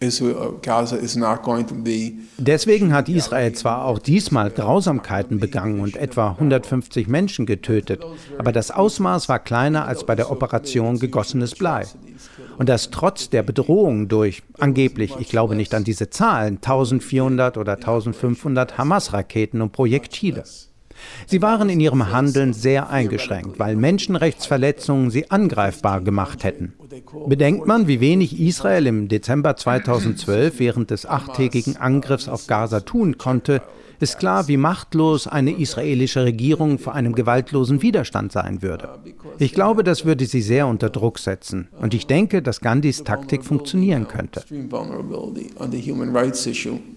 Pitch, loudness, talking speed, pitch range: 130 Hz, -20 LUFS, 130 wpm, 110-145 Hz